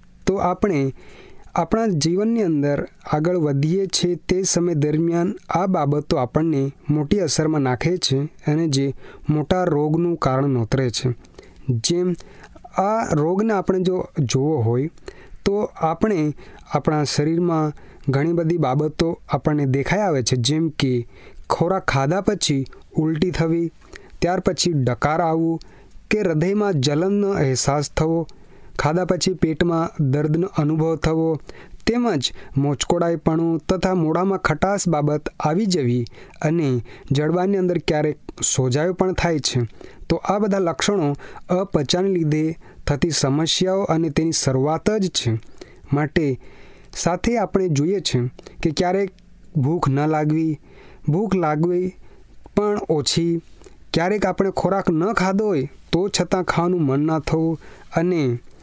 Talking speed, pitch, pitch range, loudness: 125 wpm, 165 Hz, 145-185 Hz, -21 LUFS